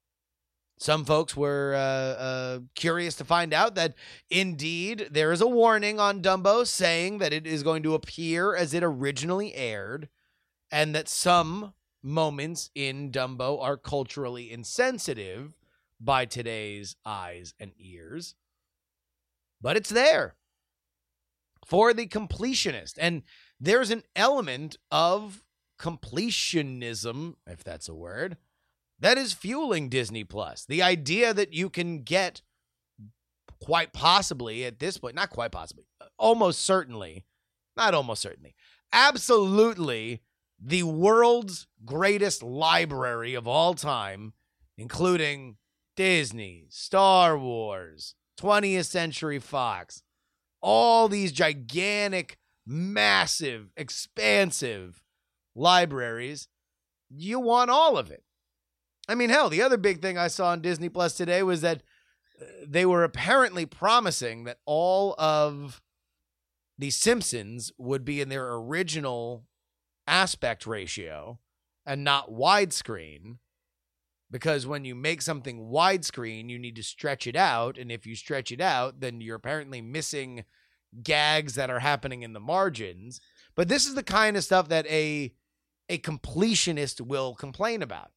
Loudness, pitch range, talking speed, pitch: -26 LUFS, 115-180 Hz, 125 wpm, 150 Hz